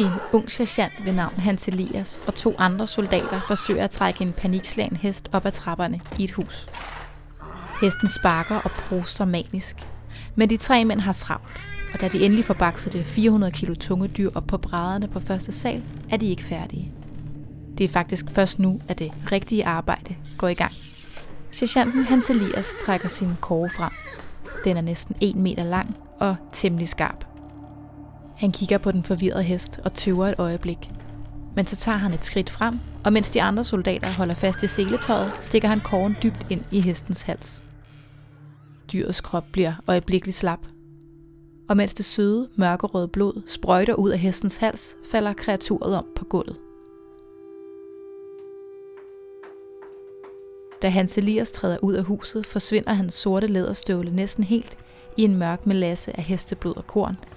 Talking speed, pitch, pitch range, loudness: 165 wpm, 190 Hz, 175-210 Hz, -24 LUFS